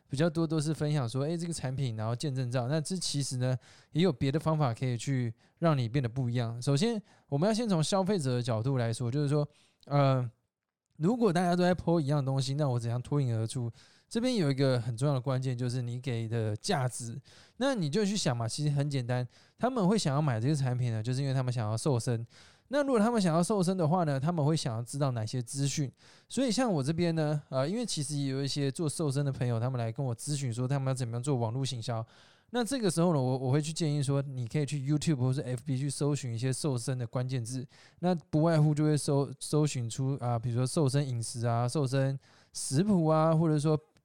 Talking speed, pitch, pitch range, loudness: 355 characters per minute, 140 Hz, 125-155 Hz, -31 LUFS